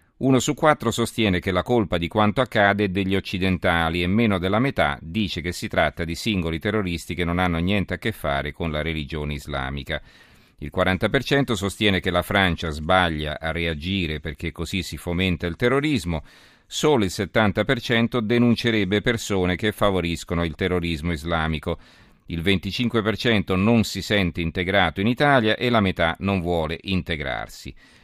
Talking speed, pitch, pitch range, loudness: 160 wpm, 95 Hz, 85-110 Hz, -22 LUFS